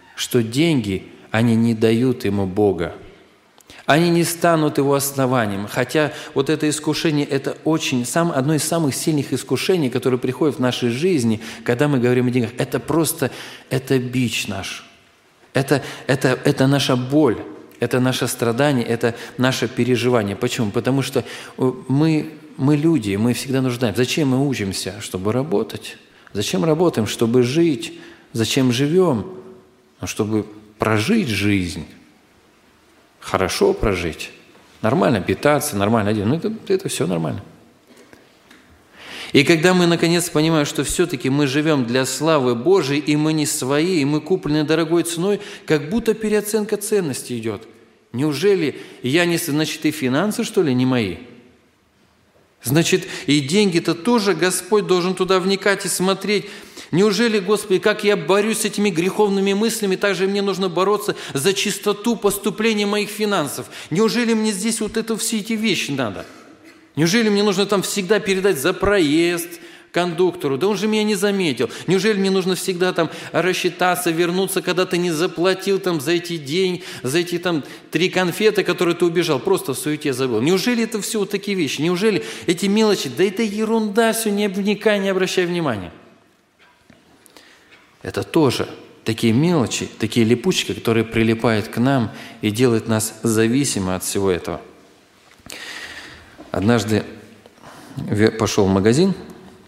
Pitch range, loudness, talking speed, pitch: 125-195 Hz, -19 LUFS, 145 wpm, 155 Hz